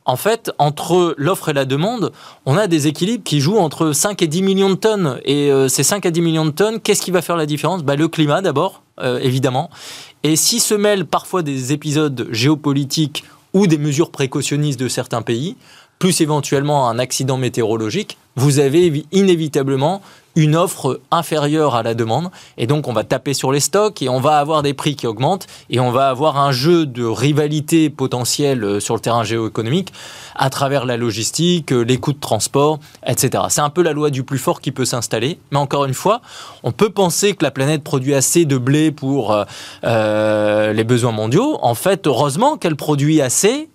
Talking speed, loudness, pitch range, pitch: 195 wpm, -16 LUFS, 130-170 Hz, 145 Hz